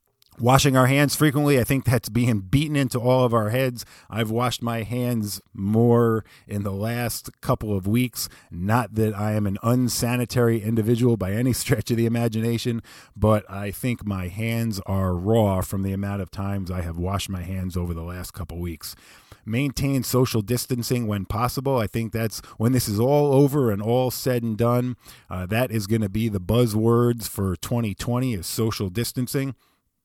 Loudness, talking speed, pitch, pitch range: -23 LUFS, 185 wpm, 115 Hz, 100-125 Hz